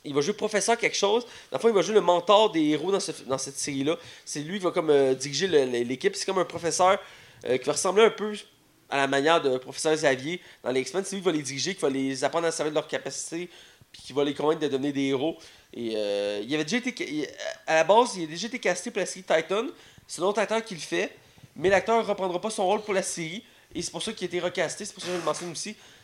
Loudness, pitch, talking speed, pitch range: -26 LUFS, 170 Hz, 285 wpm, 145-200 Hz